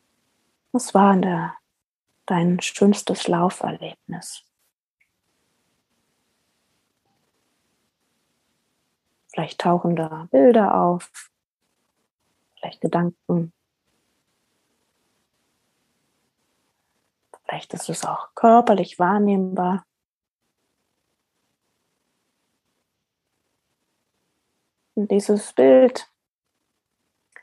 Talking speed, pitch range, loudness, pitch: 50 wpm, 175-205 Hz, -20 LUFS, 185 Hz